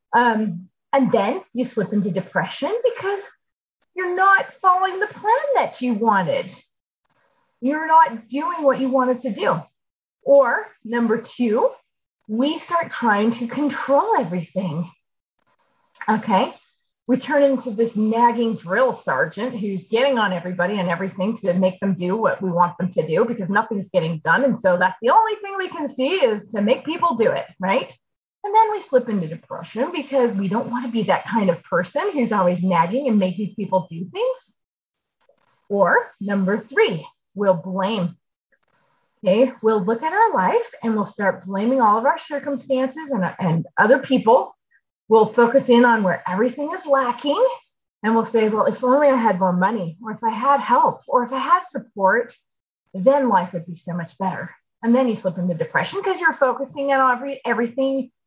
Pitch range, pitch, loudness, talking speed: 195-290 Hz, 240 Hz, -20 LUFS, 175 wpm